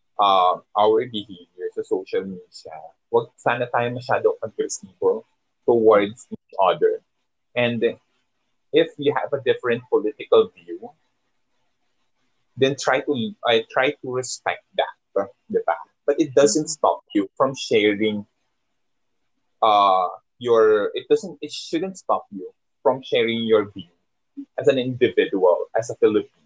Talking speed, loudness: 130 wpm, -21 LUFS